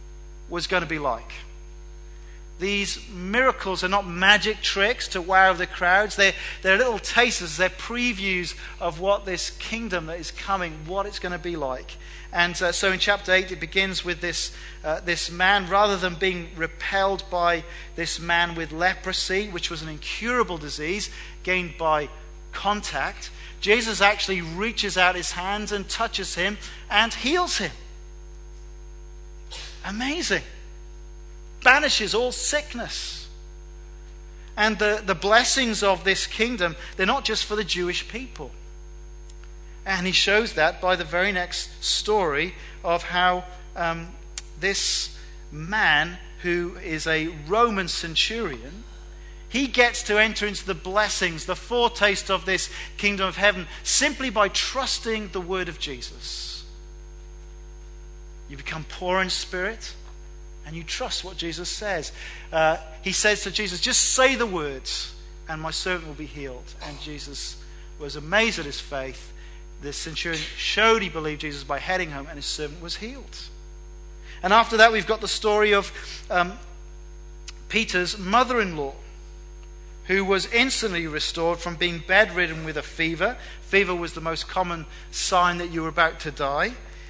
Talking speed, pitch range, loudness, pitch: 150 wpm, 150-200 Hz, -23 LUFS, 180 Hz